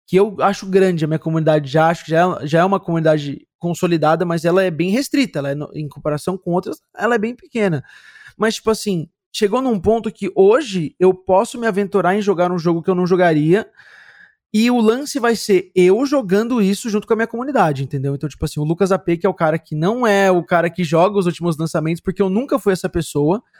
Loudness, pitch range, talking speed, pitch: -17 LUFS, 165-215 Hz, 230 wpm, 185 Hz